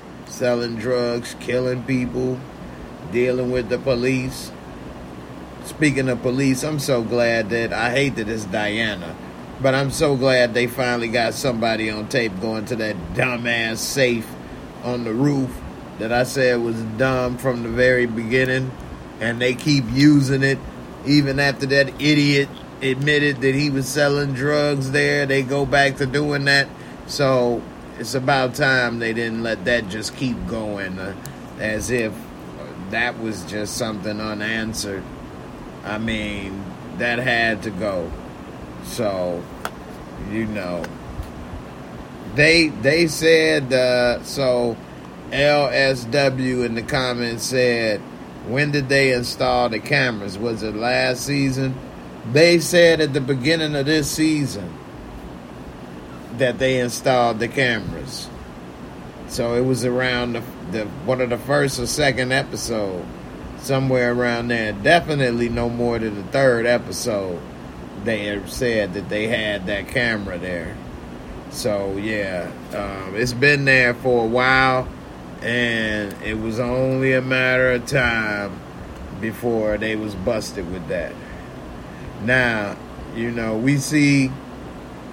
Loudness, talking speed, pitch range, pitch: -20 LUFS, 135 wpm, 105-130 Hz, 120 Hz